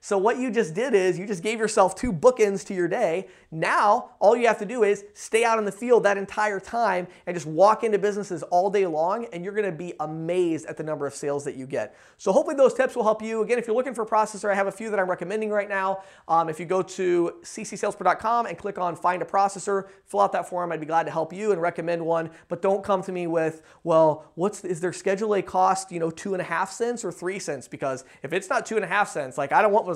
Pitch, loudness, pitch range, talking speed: 195 Hz, -24 LUFS, 175-210 Hz, 270 wpm